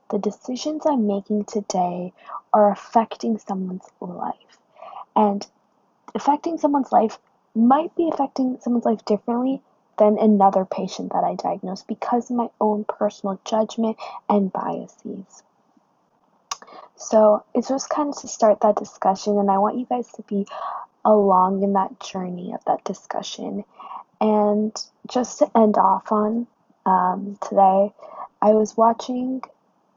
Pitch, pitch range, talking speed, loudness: 215 Hz, 200-240 Hz, 135 wpm, -21 LUFS